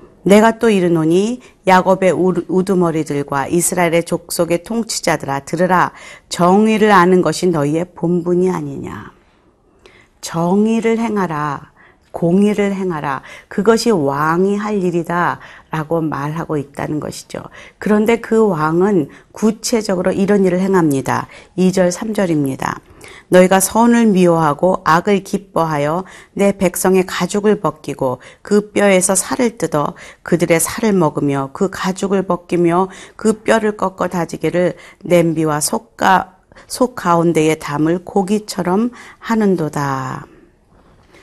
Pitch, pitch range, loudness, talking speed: 180 Hz, 165-200 Hz, -15 LUFS, 265 characters per minute